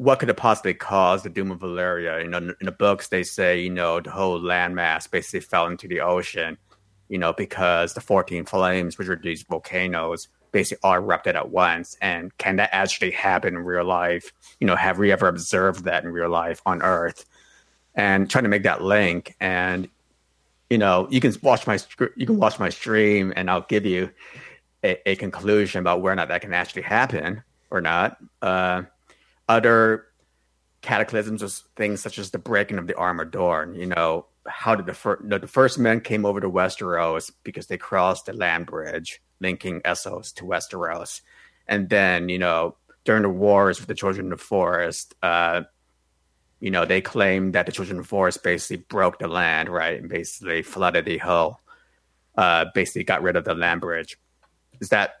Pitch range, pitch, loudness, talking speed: 85-100 Hz, 90 Hz, -22 LUFS, 190 wpm